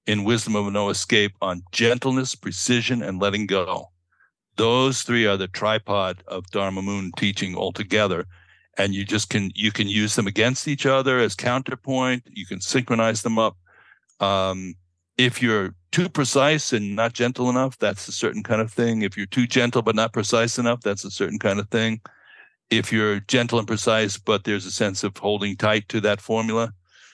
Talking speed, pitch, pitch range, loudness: 185 wpm, 110 Hz, 100-120 Hz, -22 LUFS